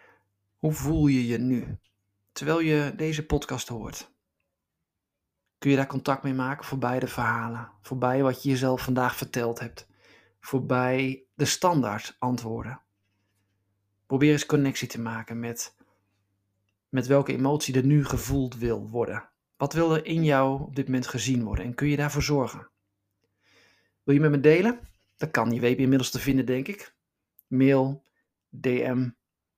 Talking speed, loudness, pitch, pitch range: 155 wpm, -26 LUFS, 125 Hz, 105-140 Hz